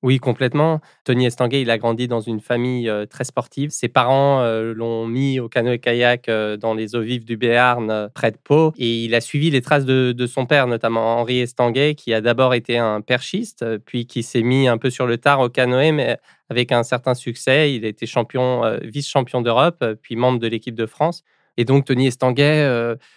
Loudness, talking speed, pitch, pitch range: -19 LUFS, 210 wpm, 125 Hz, 115-130 Hz